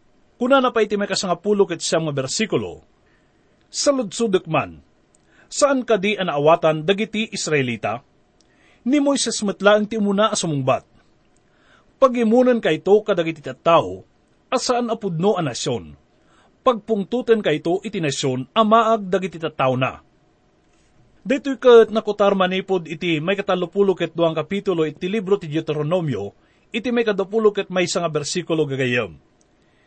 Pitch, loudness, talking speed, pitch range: 195 Hz, -20 LUFS, 135 wpm, 160-225 Hz